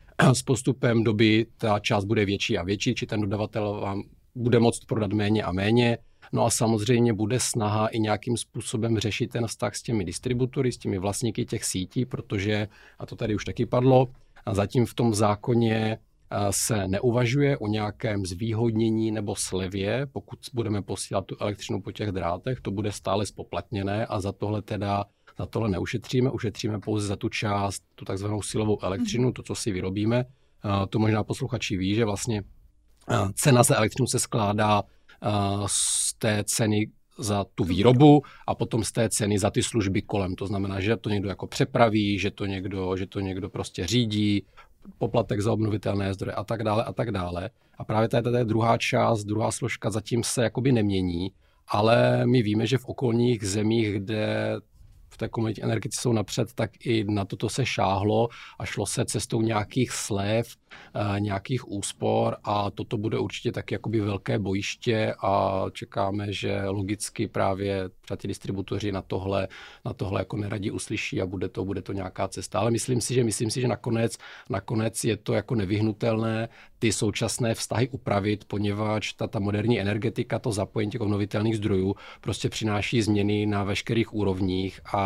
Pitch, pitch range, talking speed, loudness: 110 Hz, 100-115 Hz, 170 wpm, -26 LUFS